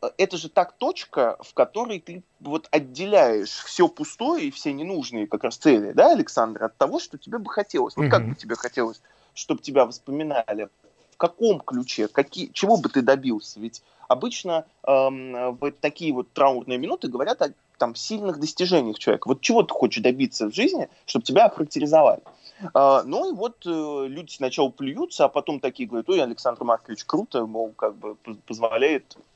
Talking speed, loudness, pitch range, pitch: 175 wpm, -23 LUFS, 125-205 Hz, 150 Hz